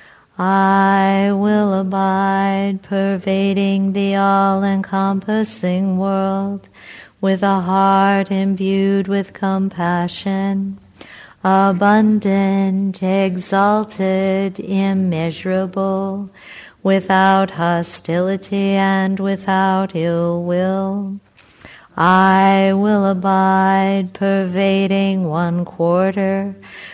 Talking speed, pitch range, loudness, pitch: 65 wpm, 190-195 Hz, -16 LUFS, 195 Hz